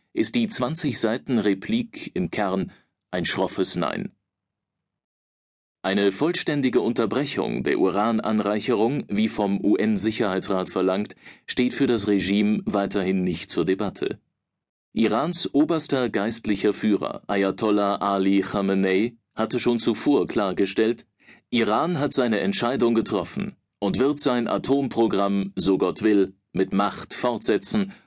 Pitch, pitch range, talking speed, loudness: 110 Hz, 100-135 Hz, 115 wpm, -23 LUFS